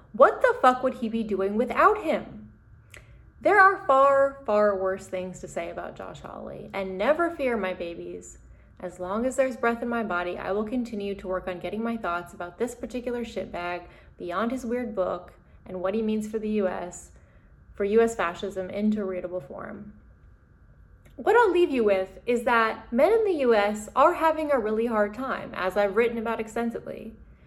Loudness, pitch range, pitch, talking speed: -25 LUFS, 185-250 Hz, 215 Hz, 185 wpm